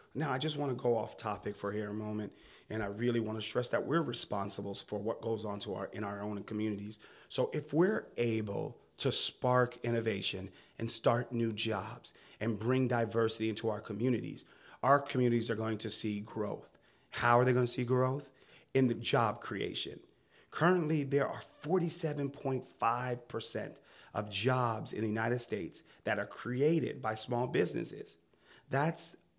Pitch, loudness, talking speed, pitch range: 115 Hz, -34 LUFS, 170 wpm, 105-130 Hz